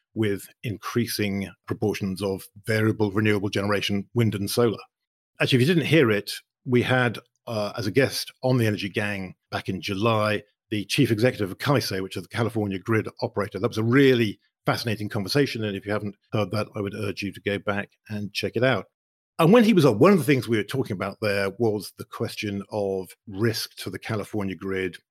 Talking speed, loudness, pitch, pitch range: 205 wpm, -25 LUFS, 105 Hz, 100-120 Hz